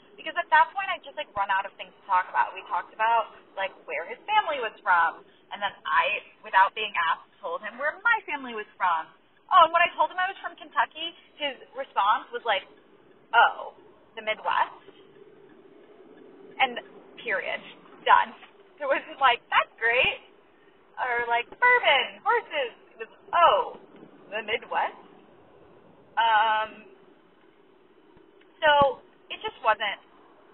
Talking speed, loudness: 150 wpm, -25 LUFS